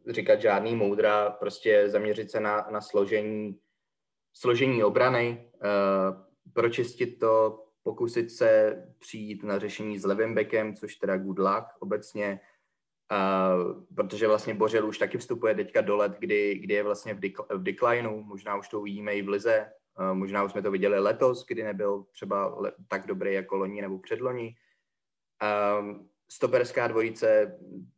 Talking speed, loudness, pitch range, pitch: 150 wpm, -28 LUFS, 100-110 Hz, 105 Hz